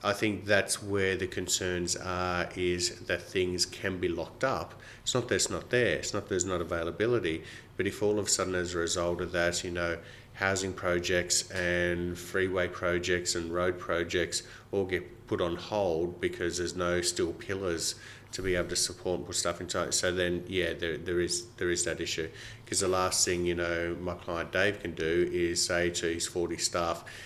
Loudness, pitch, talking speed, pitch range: -30 LUFS, 90 Hz, 205 wpm, 85-95 Hz